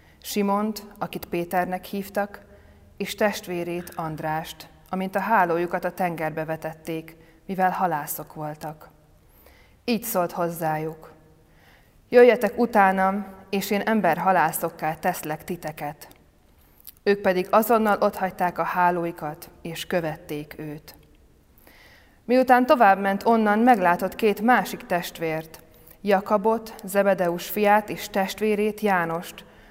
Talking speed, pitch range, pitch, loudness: 100 wpm, 160-205 Hz, 180 Hz, -23 LUFS